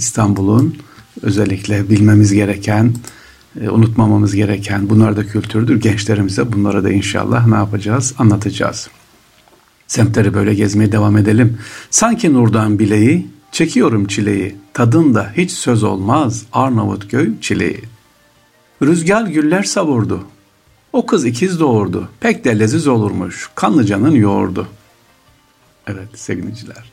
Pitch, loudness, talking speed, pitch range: 110 Hz, -14 LUFS, 105 wpm, 105-120 Hz